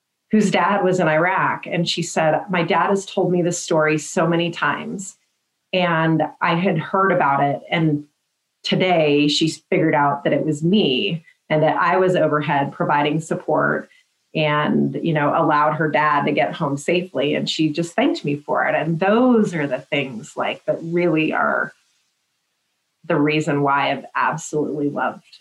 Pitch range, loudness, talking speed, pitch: 150-180 Hz, -19 LUFS, 170 wpm, 160 Hz